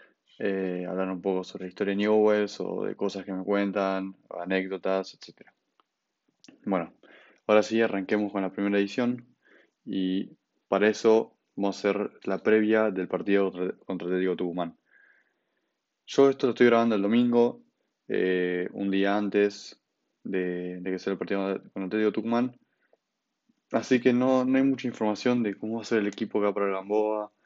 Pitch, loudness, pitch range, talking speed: 100 Hz, -27 LUFS, 95-110 Hz, 180 wpm